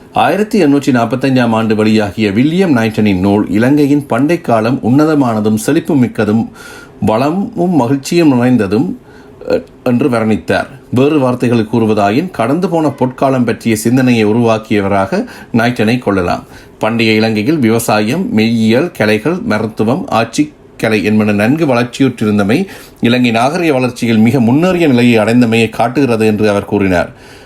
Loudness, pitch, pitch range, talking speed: -12 LUFS, 115 Hz, 110-135 Hz, 110 wpm